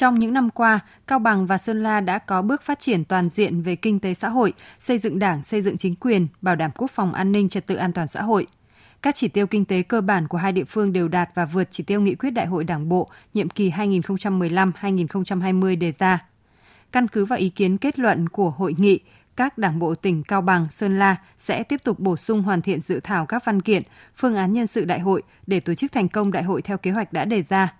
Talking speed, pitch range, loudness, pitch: 255 wpm, 185-215 Hz, -22 LUFS, 195 Hz